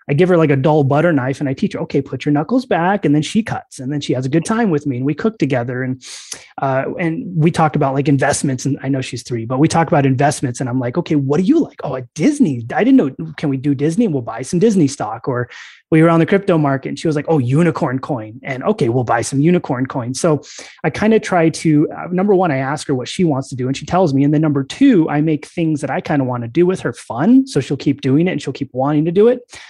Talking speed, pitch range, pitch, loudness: 295 wpm, 135-170 Hz, 150 Hz, -16 LUFS